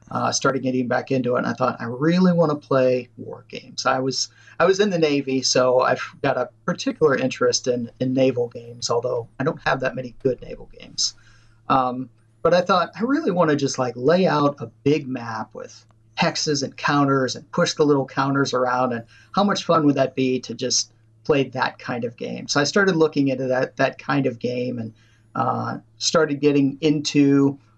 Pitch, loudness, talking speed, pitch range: 130 Hz, -21 LUFS, 205 wpm, 125-145 Hz